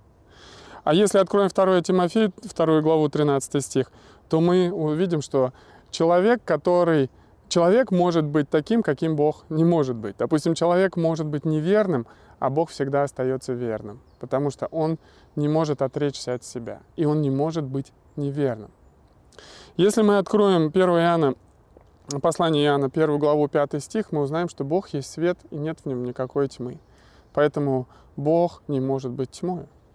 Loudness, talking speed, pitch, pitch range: -23 LUFS, 155 wpm, 150 Hz, 135-170 Hz